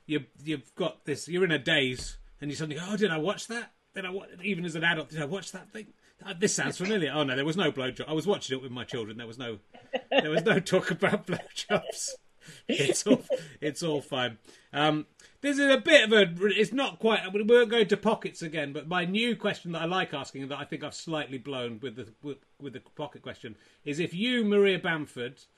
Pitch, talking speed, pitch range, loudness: 165 Hz, 240 wpm, 145-205 Hz, -28 LUFS